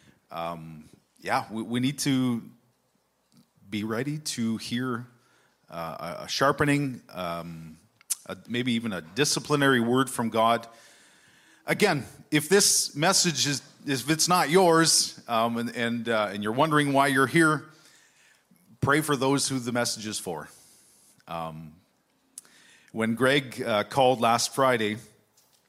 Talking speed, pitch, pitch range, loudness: 135 wpm, 125 Hz, 110-145 Hz, -25 LUFS